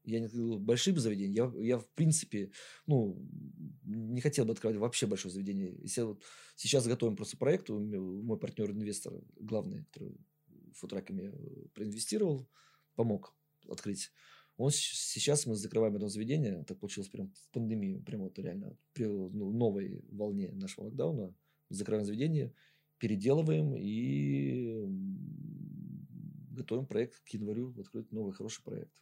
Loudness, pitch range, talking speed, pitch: -36 LUFS, 105-160 Hz, 135 wpm, 120 Hz